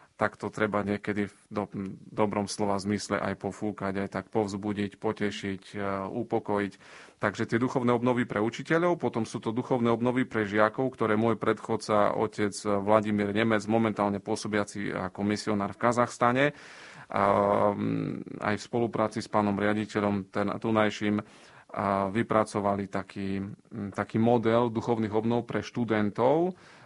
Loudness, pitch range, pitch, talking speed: -29 LUFS, 100-115 Hz, 105 Hz, 125 wpm